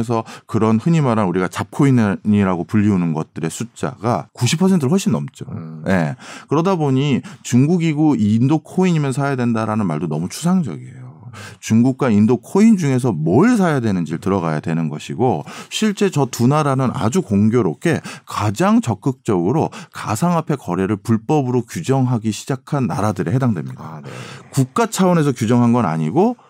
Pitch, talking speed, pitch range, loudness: 125 Hz, 345 characters per minute, 105-155 Hz, -18 LUFS